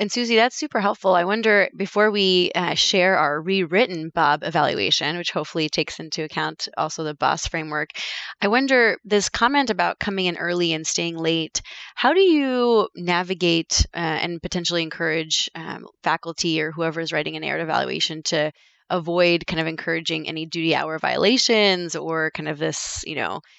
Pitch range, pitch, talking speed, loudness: 160-200 Hz, 170 Hz, 170 wpm, -21 LUFS